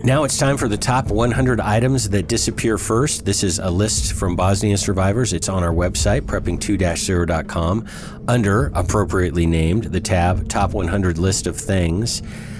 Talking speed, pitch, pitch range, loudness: 155 wpm, 100 Hz, 90-115 Hz, -19 LUFS